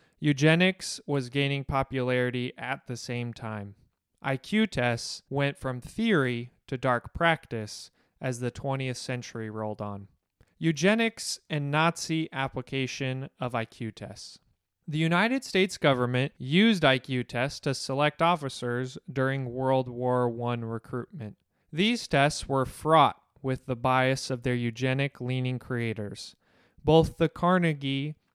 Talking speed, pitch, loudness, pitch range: 125 wpm, 130 Hz, -28 LUFS, 120-150 Hz